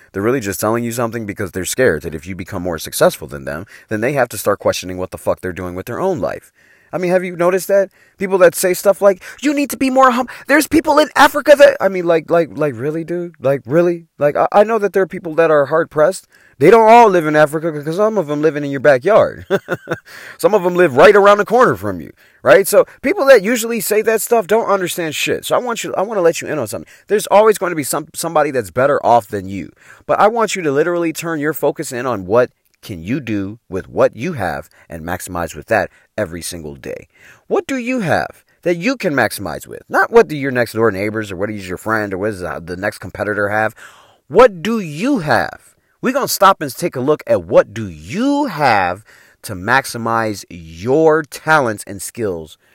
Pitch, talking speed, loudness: 155 Hz, 240 wpm, -15 LUFS